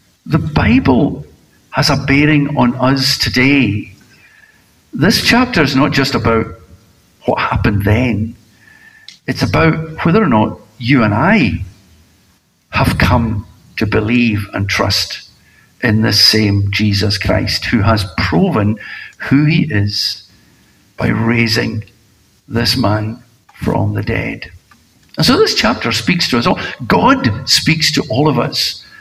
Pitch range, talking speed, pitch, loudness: 105-130 Hz, 130 wpm, 115 Hz, -13 LUFS